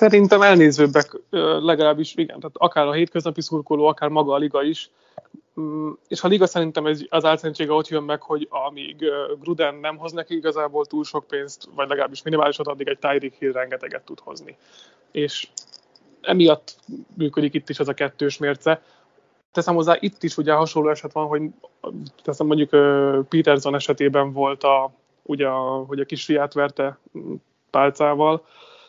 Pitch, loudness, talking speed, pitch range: 150 Hz, -21 LUFS, 155 wpm, 145-165 Hz